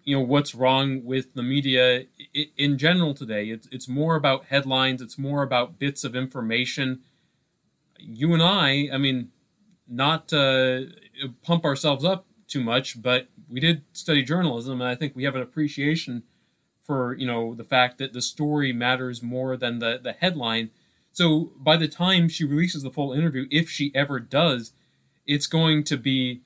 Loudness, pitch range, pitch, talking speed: -24 LUFS, 125-155 Hz, 135 Hz, 175 wpm